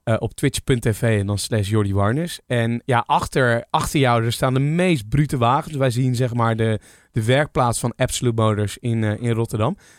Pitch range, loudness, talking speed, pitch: 110-130 Hz, -20 LUFS, 200 wpm, 120 Hz